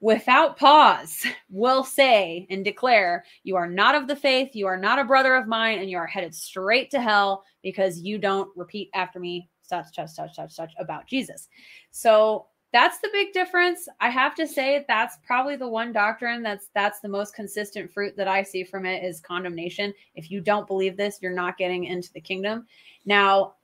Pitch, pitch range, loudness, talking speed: 205 Hz, 185-250 Hz, -23 LUFS, 200 wpm